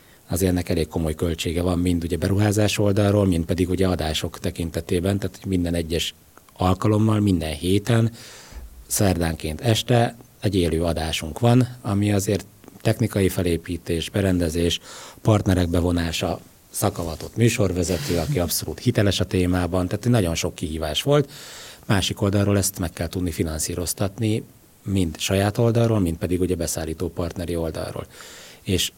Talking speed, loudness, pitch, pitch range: 130 wpm, -23 LUFS, 90 Hz, 85-105 Hz